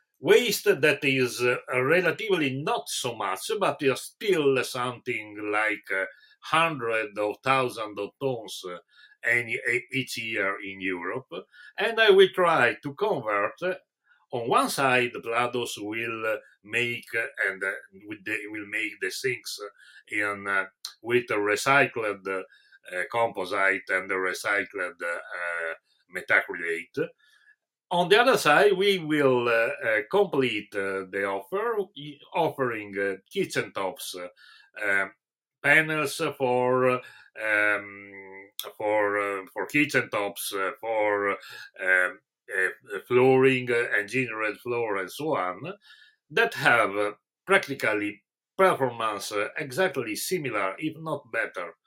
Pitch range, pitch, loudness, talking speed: 105-155 Hz, 125 Hz, -26 LUFS, 125 wpm